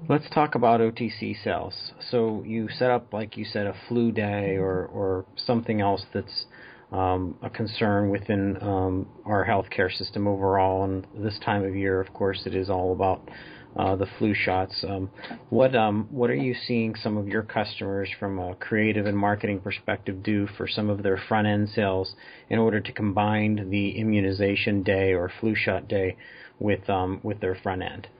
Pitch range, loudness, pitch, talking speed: 95-110 Hz, -26 LUFS, 100 Hz, 185 wpm